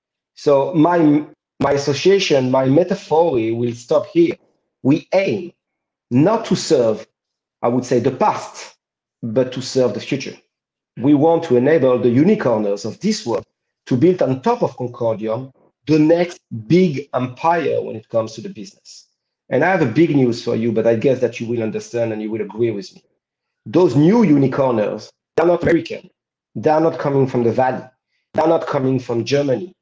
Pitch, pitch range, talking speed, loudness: 135 Hz, 120-165 Hz, 180 wpm, -17 LUFS